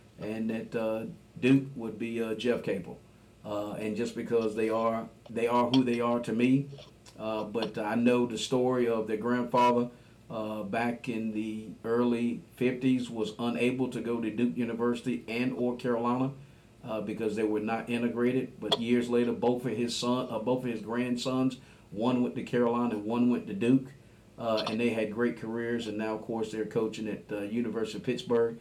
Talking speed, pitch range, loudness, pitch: 190 wpm, 110-120 Hz, -30 LUFS, 120 Hz